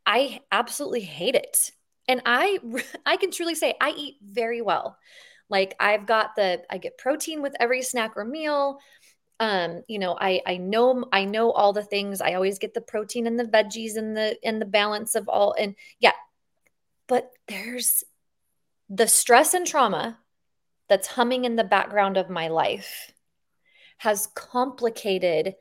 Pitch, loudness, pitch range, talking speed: 230 Hz, -24 LUFS, 205-255 Hz, 165 wpm